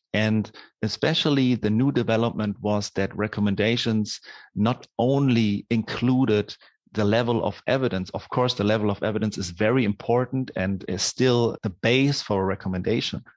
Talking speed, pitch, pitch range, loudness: 145 wpm, 110 Hz, 105-125 Hz, -24 LUFS